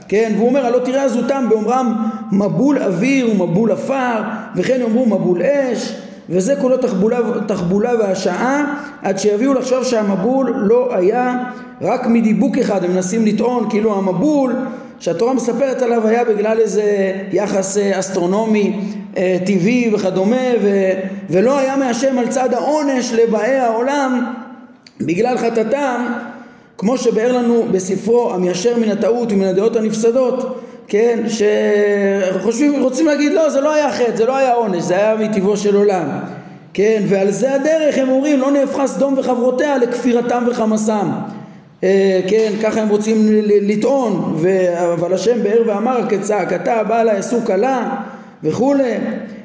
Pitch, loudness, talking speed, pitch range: 230 Hz, -16 LUFS, 135 wpm, 205-255 Hz